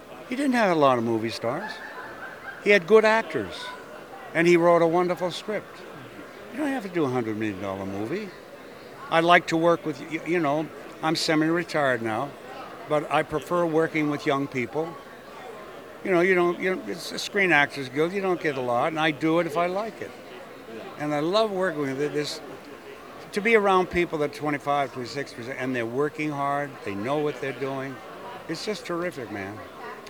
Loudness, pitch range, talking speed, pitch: -25 LUFS, 140-175 Hz, 190 wpm, 155 Hz